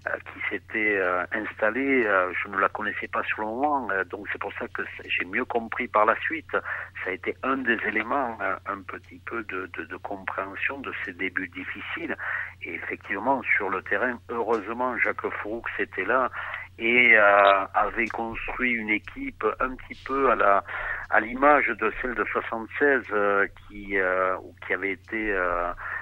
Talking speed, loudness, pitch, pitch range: 180 wpm, -25 LUFS, 110 Hz, 100-120 Hz